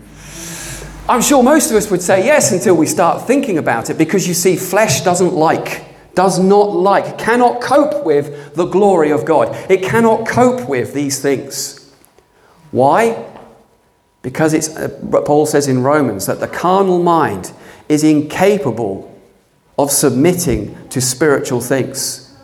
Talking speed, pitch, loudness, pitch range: 145 wpm, 165 Hz, -14 LUFS, 140-195 Hz